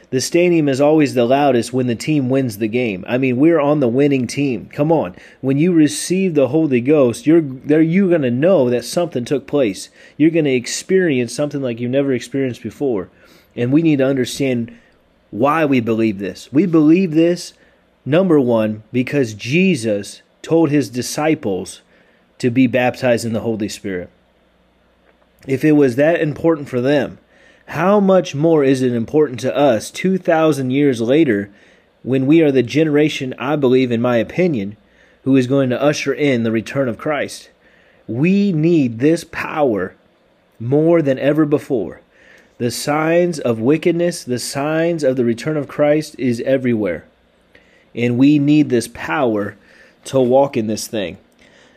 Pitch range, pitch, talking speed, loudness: 120-155 Hz, 135 Hz, 165 wpm, -16 LUFS